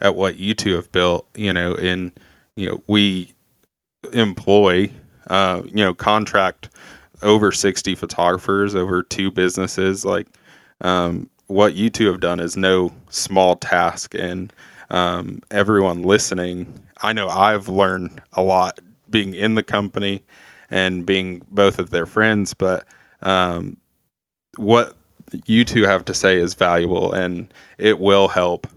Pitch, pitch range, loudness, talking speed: 95 Hz, 90-100 Hz, -18 LUFS, 140 wpm